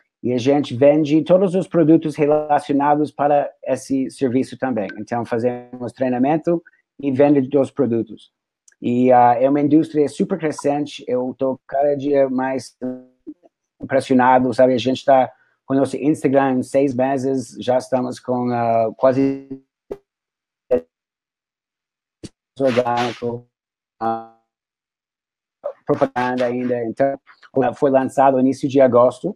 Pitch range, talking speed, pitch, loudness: 125-145 Hz, 115 wpm, 135 Hz, -18 LUFS